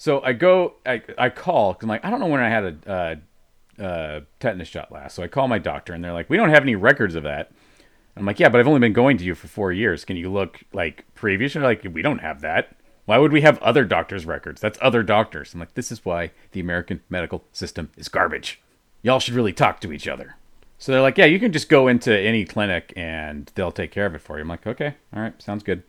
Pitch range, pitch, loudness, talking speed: 85-125 Hz, 100 Hz, -20 LUFS, 265 wpm